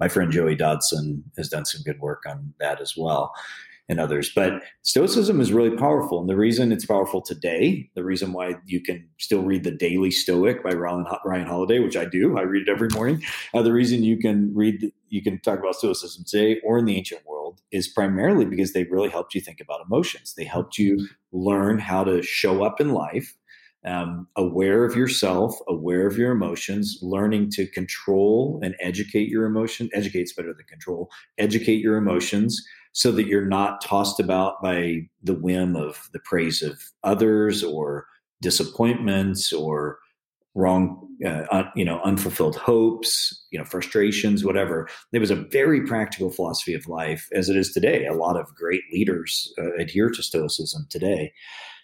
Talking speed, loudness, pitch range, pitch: 180 wpm, -23 LUFS, 90-110 Hz, 95 Hz